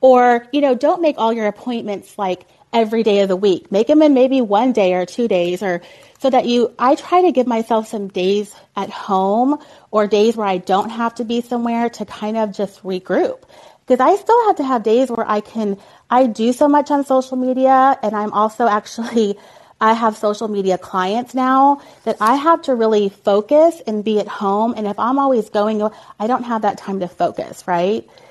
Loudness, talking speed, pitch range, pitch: -17 LUFS, 210 wpm, 205-255 Hz, 225 Hz